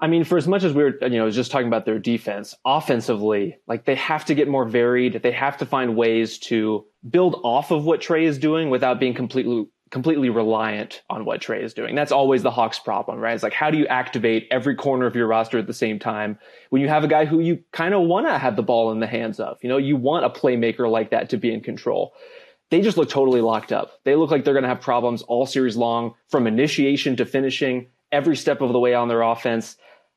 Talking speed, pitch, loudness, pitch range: 250 wpm, 125 Hz, -21 LUFS, 115-150 Hz